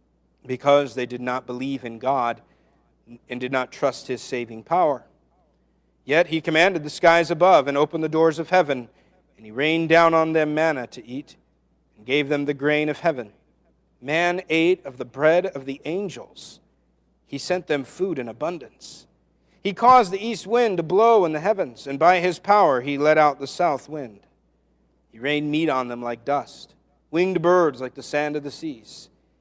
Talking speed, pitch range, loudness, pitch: 185 wpm, 125-170 Hz, -21 LUFS, 150 Hz